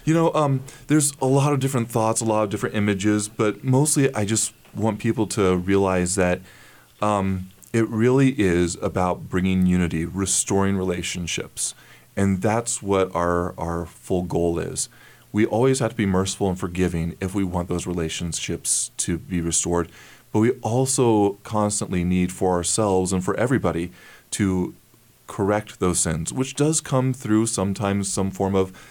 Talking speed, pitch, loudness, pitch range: 160 wpm, 100 Hz, -22 LUFS, 90-115 Hz